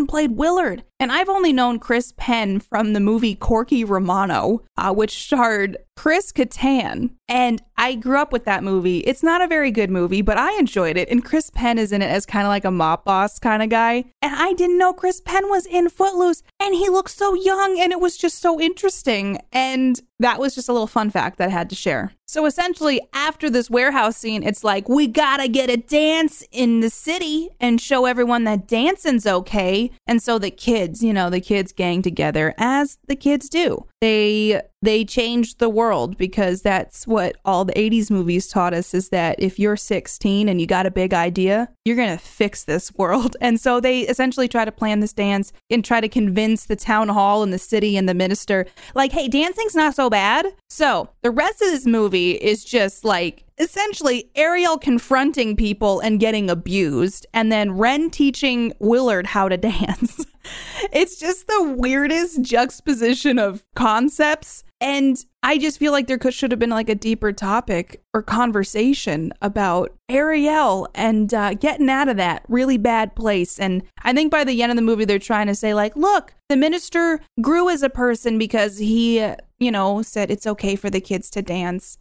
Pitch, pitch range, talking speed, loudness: 230 Hz, 205-280 Hz, 195 wpm, -19 LUFS